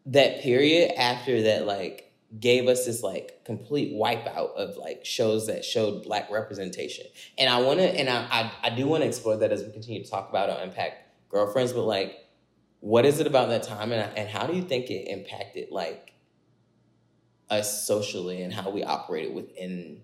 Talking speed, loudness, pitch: 190 wpm, -26 LUFS, 120 Hz